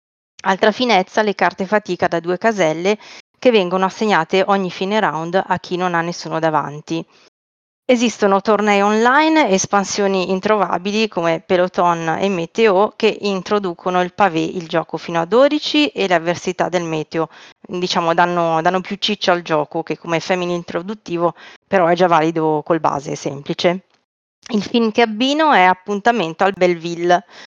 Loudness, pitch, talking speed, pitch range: -17 LUFS, 185 Hz, 150 wpm, 170-210 Hz